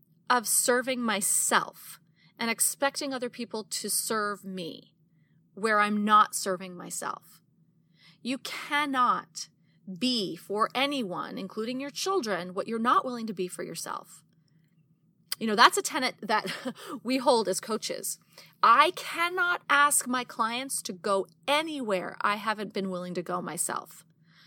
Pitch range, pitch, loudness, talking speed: 180-255 Hz, 215 Hz, -27 LUFS, 135 wpm